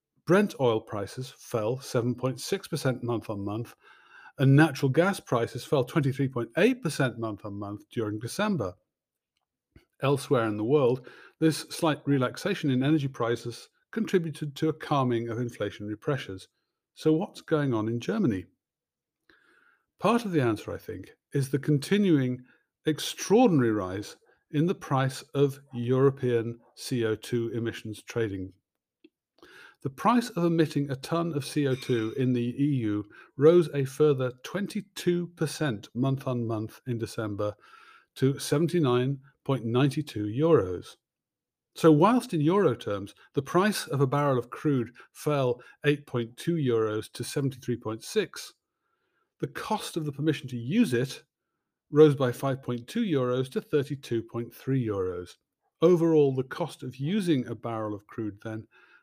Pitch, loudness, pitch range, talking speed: 135 Hz, -28 LUFS, 120-155 Hz, 130 wpm